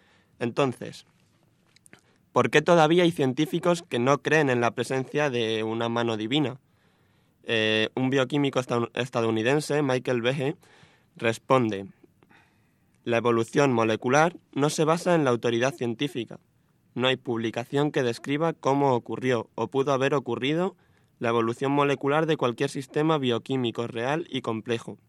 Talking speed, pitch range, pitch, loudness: 130 wpm, 115-145 Hz, 130 Hz, -25 LUFS